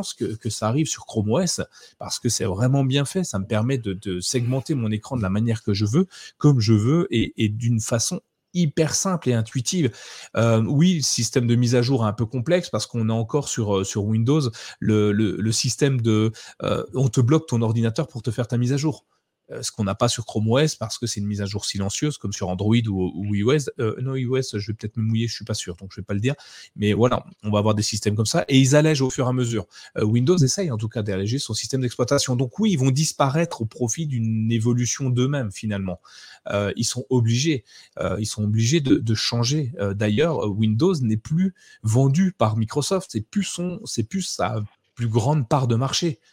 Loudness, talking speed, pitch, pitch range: -22 LUFS, 240 wpm, 120 Hz, 110-140 Hz